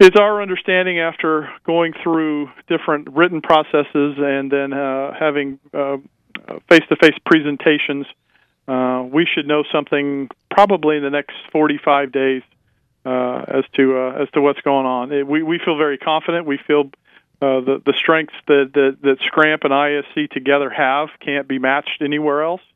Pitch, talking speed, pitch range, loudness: 145 Hz, 160 wpm, 140-160 Hz, -17 LUFS